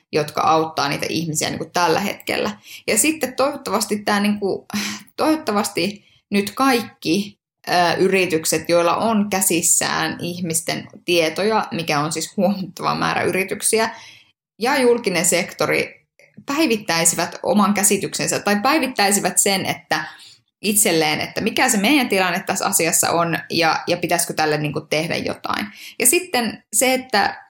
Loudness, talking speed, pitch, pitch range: -19 LUFS, 135 wpm, 185 Hz, 165-215 Hz